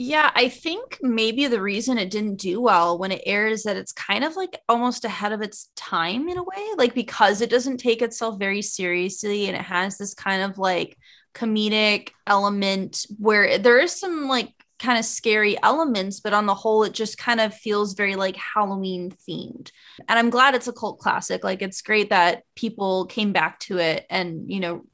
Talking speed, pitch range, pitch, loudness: 205 wpm, 195-240 Hz, 215 Hz, -22 LUFS